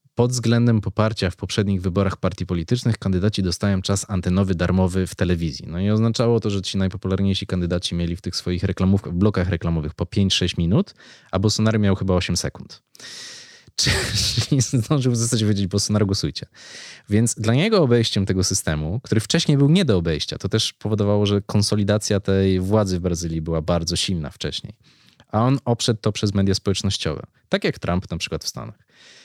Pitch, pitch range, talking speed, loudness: 100 Hz, 90-110 Hz, 175 wpm, -21 LUFS